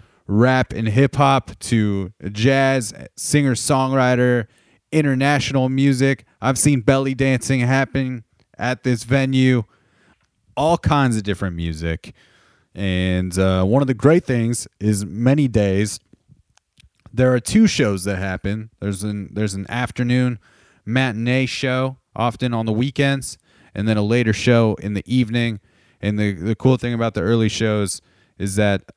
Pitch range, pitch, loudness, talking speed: 105-130 Hz, 120 Hz, -19 LUFS, 145 wpm